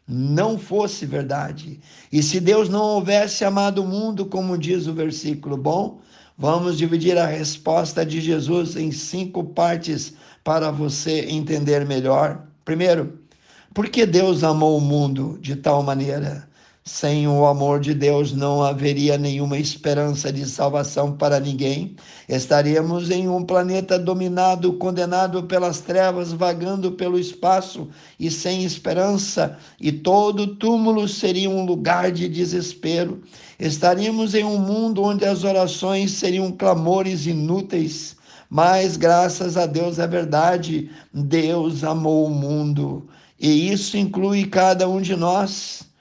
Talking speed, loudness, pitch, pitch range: 130 wpm, -20 LUFS, 170 Hz, 150-185 Hz